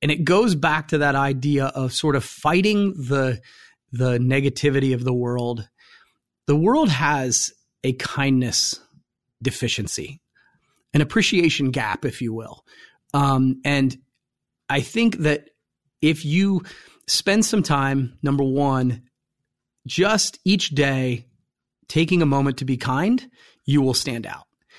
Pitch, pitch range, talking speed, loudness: 140 Hz, 130-155 Hz, 130 wpm, -21 LUFS